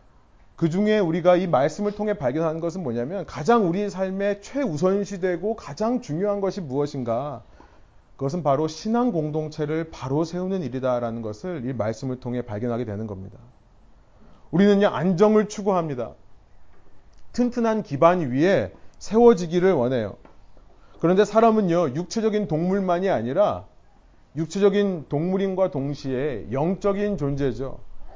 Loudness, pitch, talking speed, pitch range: -23 LUFS, 170 Hz, 305 characters per minute, 130-200 Hz